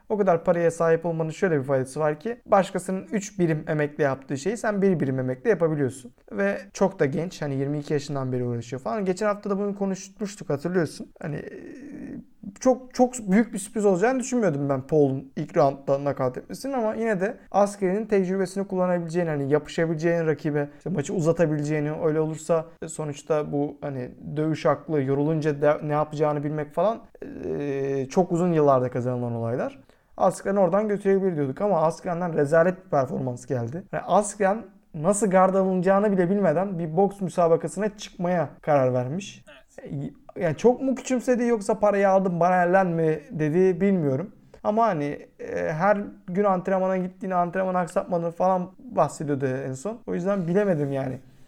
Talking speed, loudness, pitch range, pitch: 155 wpm, -25 LUFS, 150-200 Hz, 175 Hz